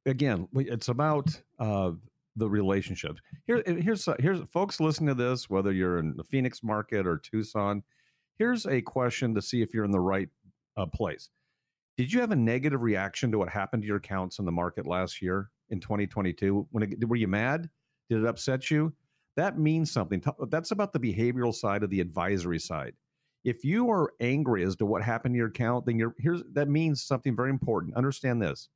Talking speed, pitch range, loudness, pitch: 195 wpm, 100-145 Hz, -29 LUFS, 120 Hz